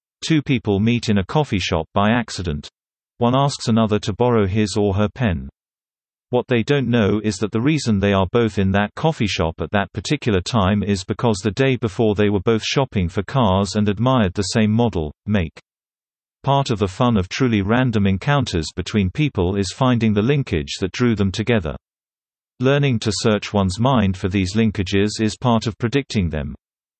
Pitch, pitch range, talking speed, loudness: 105 Hz, 100-120 Hz, 190 wpm, -19 LUFS